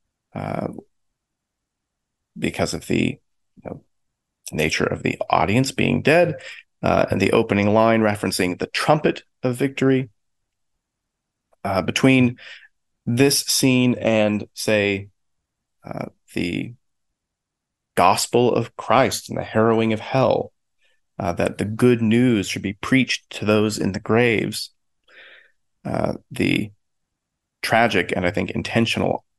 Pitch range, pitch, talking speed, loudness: 100-125 Hz, 110 Hz, 120 wpm, -20 LUFS